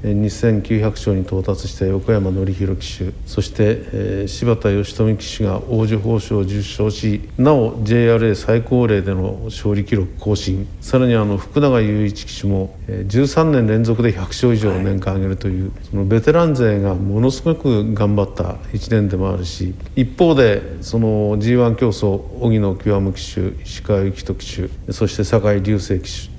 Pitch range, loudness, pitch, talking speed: 95-115 Hz, -18 LUFS, 105 Hz, 290 characters per minute